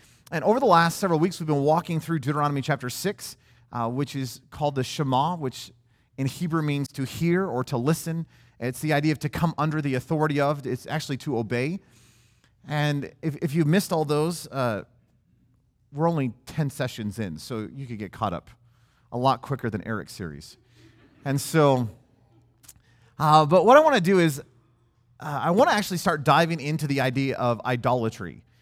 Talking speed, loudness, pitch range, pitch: 185 wpm, -24 LUFS, 120-155 Hz, 135 Hz